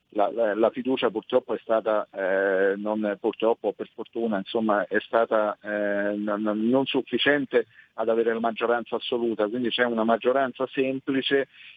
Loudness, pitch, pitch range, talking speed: -25 LUFS, 115 Hz, 105-130 Hz, 145 wpm